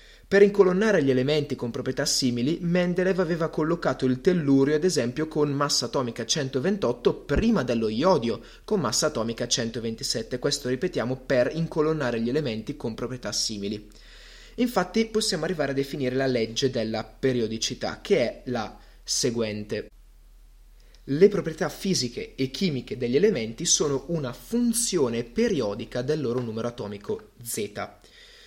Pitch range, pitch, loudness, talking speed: 120-180 Hz, 140 Hz, -25 LUFS, 135 wpm